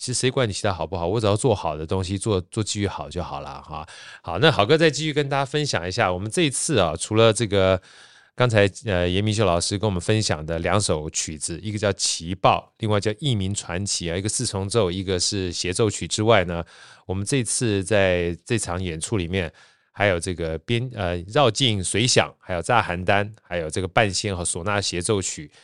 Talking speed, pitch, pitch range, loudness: 315 characters per minute, 100 Hz, 90-115 Hz, -22 LUFS